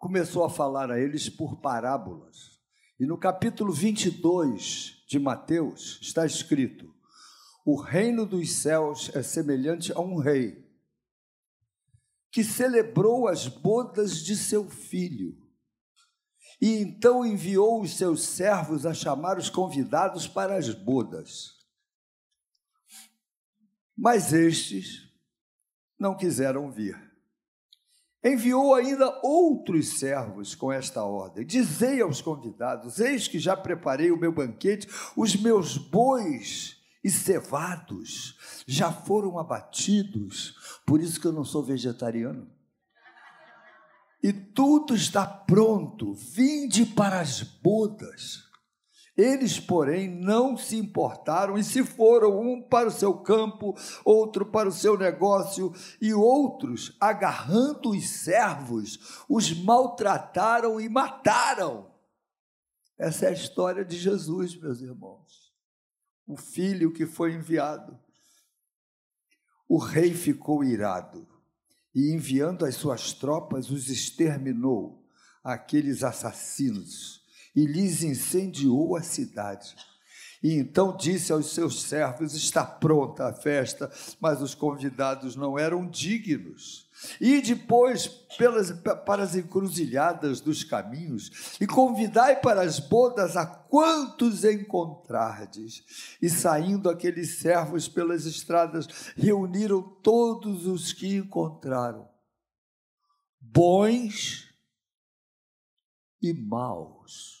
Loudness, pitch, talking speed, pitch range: -26 LUFS, 180 Hz, 110 wpm, 150-215 Hz